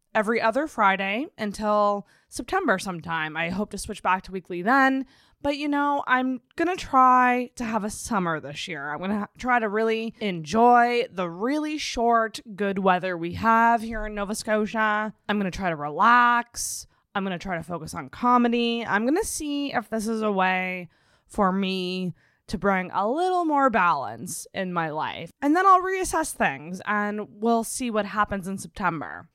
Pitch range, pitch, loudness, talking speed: 190-245 Hz, 215 Hz, -24 LUFS, 175 wpm